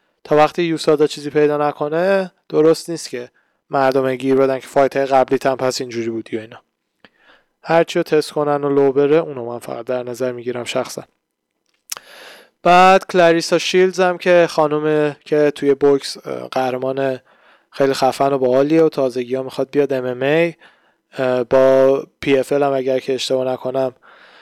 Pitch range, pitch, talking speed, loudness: 130-155 Hz, 140 Hz, 155 wpm, -17 LUFS